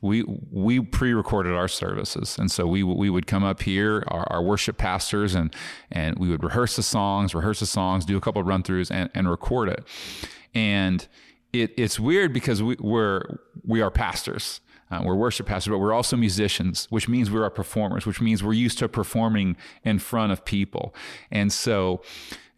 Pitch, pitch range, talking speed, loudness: 105 Hz, 95-115 Hz, 190 wpm, -24 LUFS